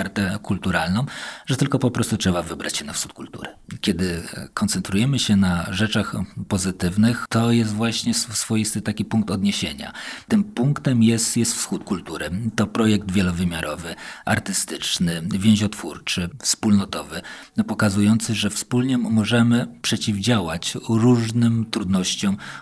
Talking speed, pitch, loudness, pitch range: 115 wpm, 110 Hz, -21 LUFS, 100-115 Hz